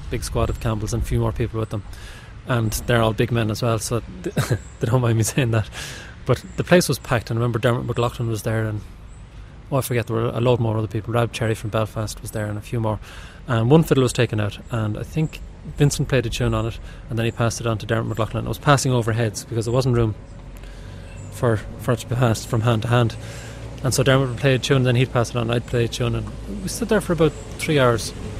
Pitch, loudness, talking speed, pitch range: 115 Hz, -22 LUFS, 265 wpm, 110-125 Hz